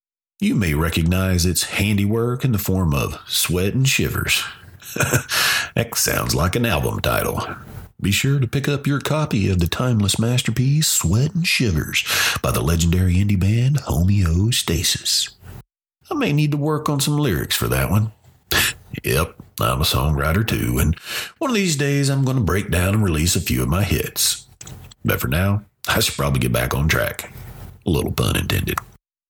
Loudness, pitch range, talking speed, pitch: -19 LUFS, 90-130 Hz, 175 wpm, 105 Hz